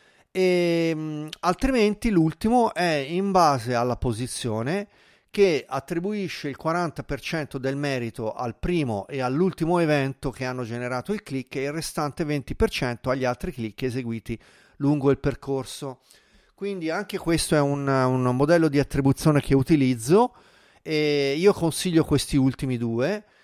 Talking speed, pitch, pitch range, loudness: 135 wpm, 145 Hz, 130-175 Hz, -24 LUFS